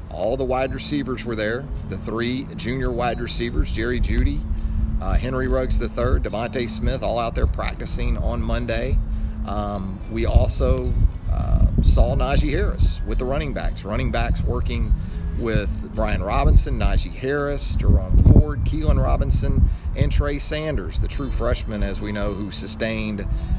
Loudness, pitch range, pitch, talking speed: -23 LUFS, 90-120 Hz, 105 Hz, 150 wpm